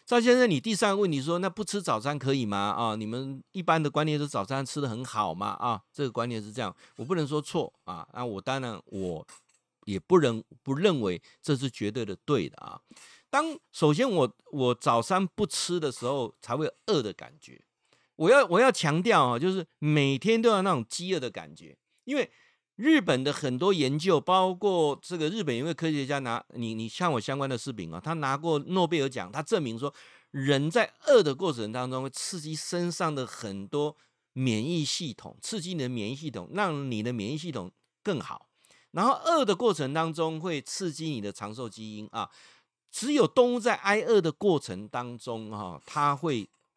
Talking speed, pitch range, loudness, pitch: 280 characters per minute, 120-180 Hz, -28 LUFS, 145 Hz